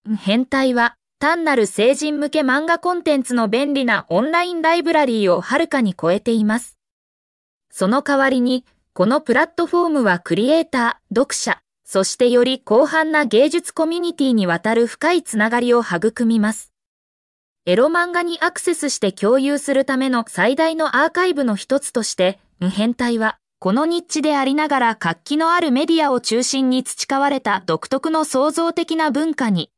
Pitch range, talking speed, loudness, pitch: 225-310 Hz, 345 characters per minute, -18 LUFS, 265 Hz